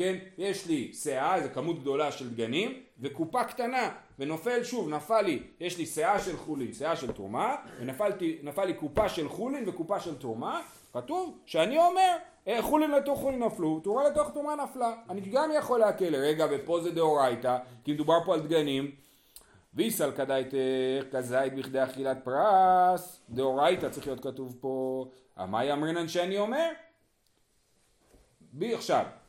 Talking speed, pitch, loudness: 150 wpm, 170 Hz, -30 LUFS